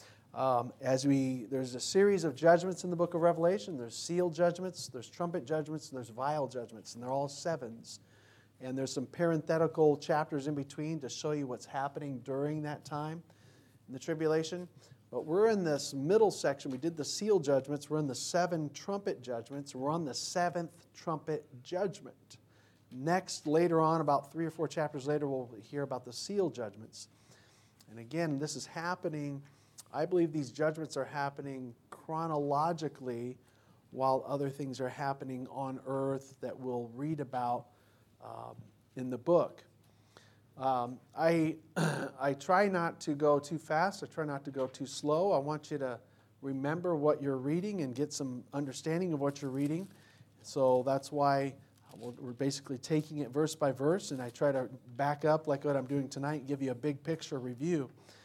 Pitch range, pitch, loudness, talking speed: 130-155 Hz, 140 Hz, -34 LUFS, 175 wpm